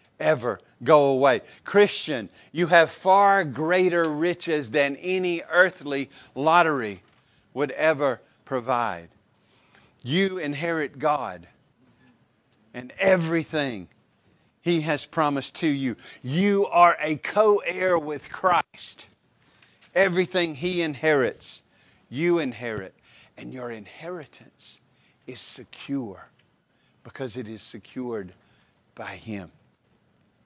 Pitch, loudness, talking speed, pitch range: 150 Hz, -23 LUFS, 95 wpm, 125-175 Hz